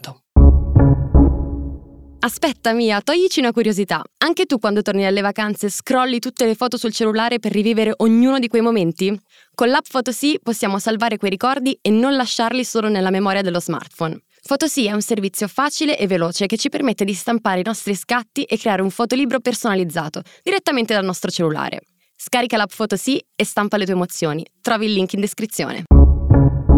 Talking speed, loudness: 170 wpm, -18 LUFS